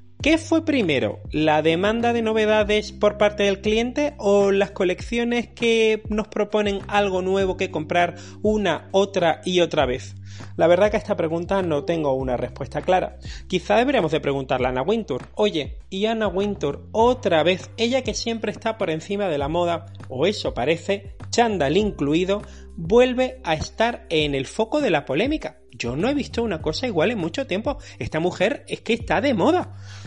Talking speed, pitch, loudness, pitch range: 180 wpm, 195 Hz, -22 LUFS, 160-220 Hz